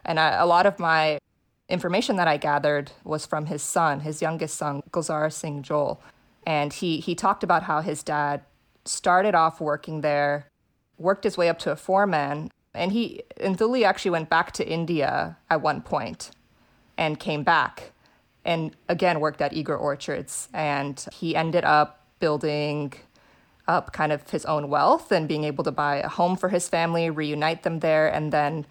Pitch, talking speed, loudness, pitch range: 155 Hz, 180 wpm, -24 LUFS, 150-170 Hz